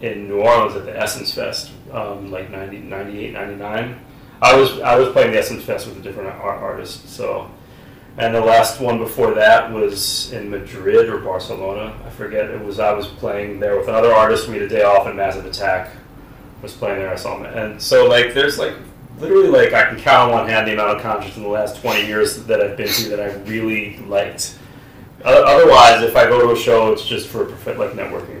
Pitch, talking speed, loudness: 125 Hz, 220 wpm, -15 LUFS